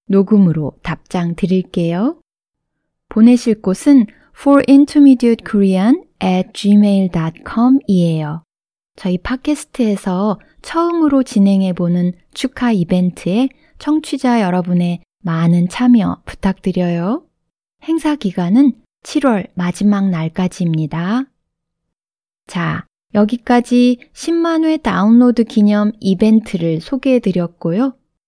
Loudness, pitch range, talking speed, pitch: -15 LUFS, 180-255 Hz, 270 characters per minute, 210 Hz